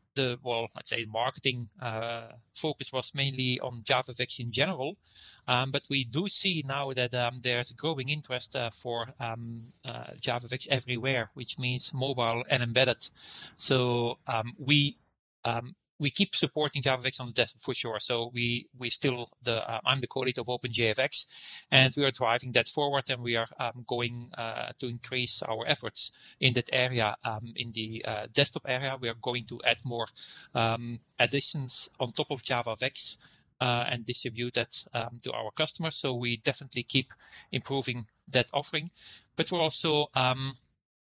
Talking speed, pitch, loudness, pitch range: 170 wpm, 125 Hz, -30 LUFS, 120-140 Hz